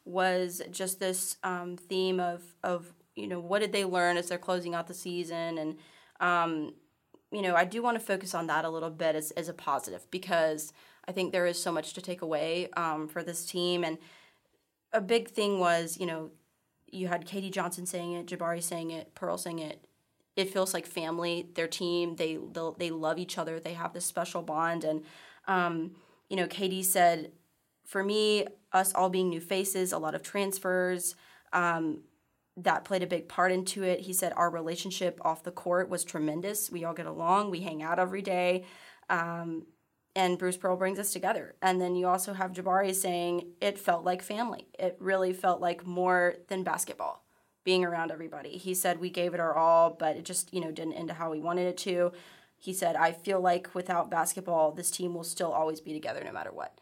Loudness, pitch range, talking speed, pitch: -31 LUFS, 165-185 Hz, 205 wpm, 175 Hz